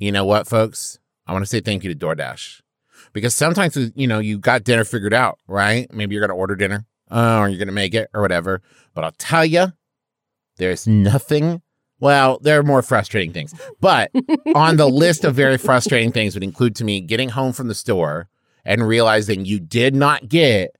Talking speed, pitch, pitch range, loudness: 210 wpm, 120 Hz, 105-140 Hz, -17 LUFS